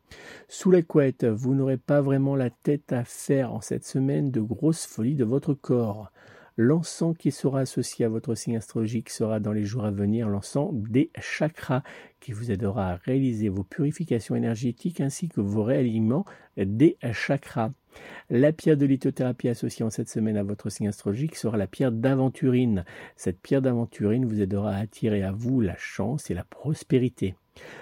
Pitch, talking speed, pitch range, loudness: 125 Hz, 175 wpm, 110-140 Hz, -26 LUFS